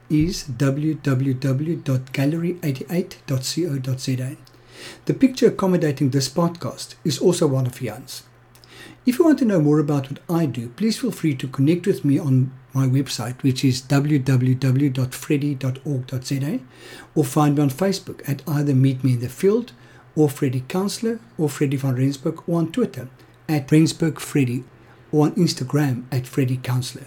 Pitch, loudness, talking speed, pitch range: 140 Hz, -21 LUFS, 145 wpm, 130-160 Hz